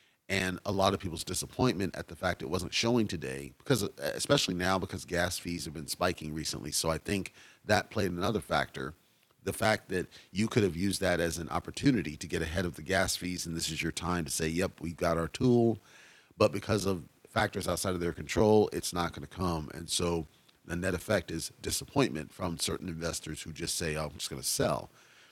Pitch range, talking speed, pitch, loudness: 80-95 Hz, 220 wpm, 90 Hz, -32 LUFS